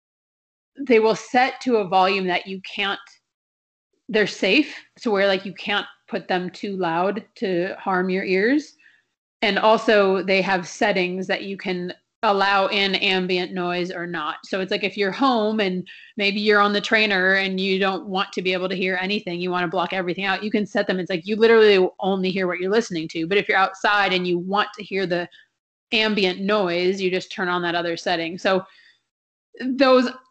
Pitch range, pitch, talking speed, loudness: 185-210 Hz, 195 Hz, 200 wpm, -21 LUFS